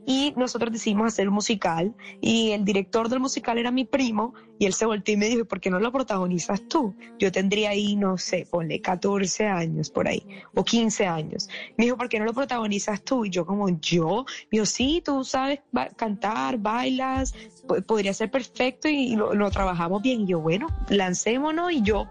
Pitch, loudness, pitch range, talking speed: 220 Hz, -25 LUFS, 195-245 Hz, 205 wpm